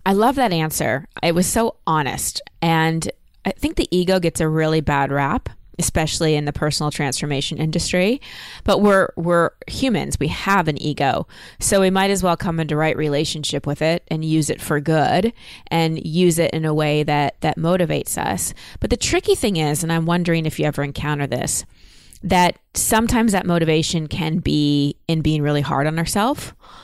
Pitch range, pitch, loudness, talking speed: 150-180 Hz, 160 Hz, -19 LUFS, 185 wpm